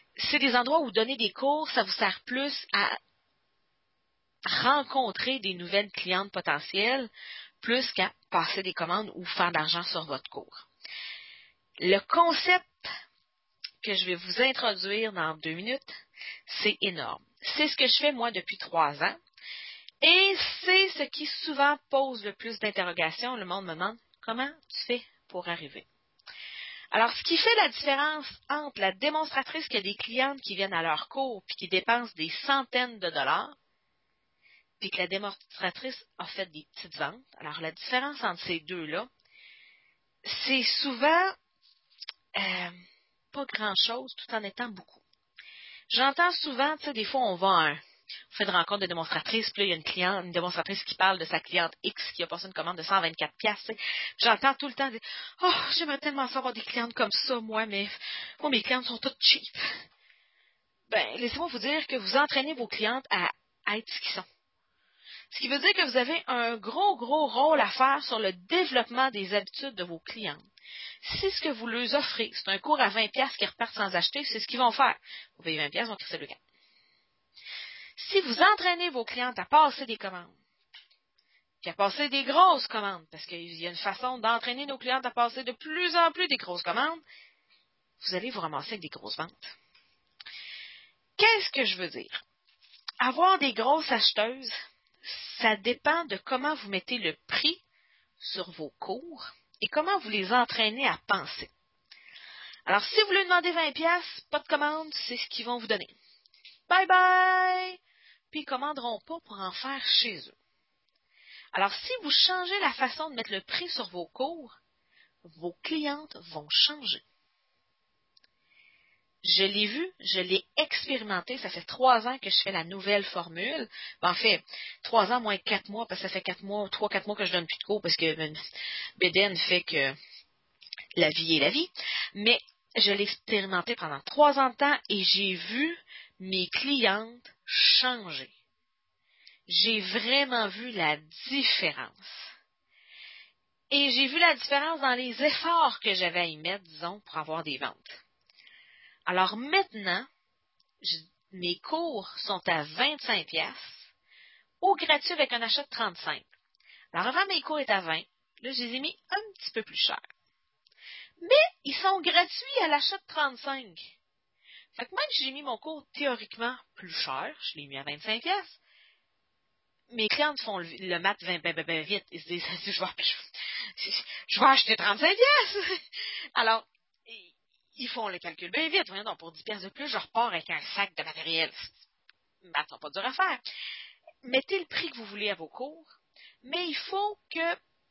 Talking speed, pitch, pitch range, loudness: 175 wpm, 235 Hz, 190-290 Hz, -28 LUFS